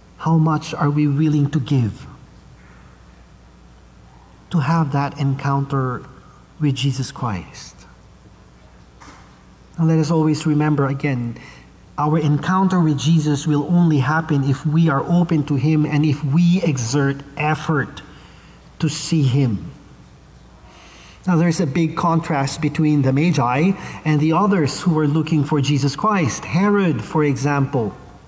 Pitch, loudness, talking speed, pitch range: 150 Hz, -19 LUFS, 130 wpm, 140-160 Hz